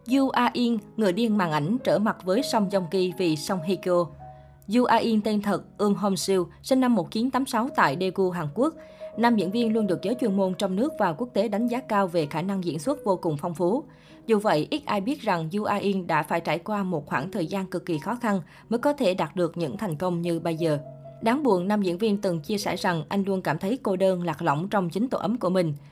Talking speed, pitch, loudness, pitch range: 255 wpm, 195 Hz, -25 LUFS, 175-225 Hz